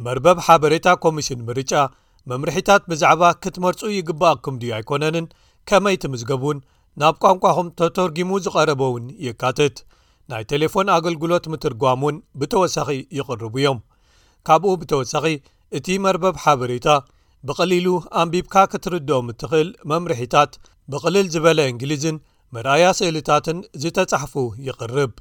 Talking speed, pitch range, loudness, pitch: 100 wpm, 135-180 Hz, -19 LUFS, 155 Hz